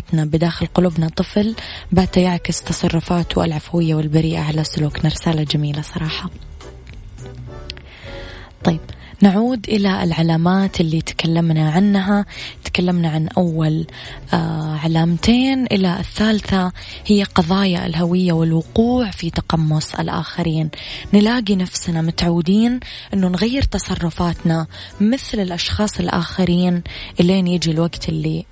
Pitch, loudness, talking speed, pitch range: 170 Hz, -18 LUFS, 95 wpm, 160-190 Hz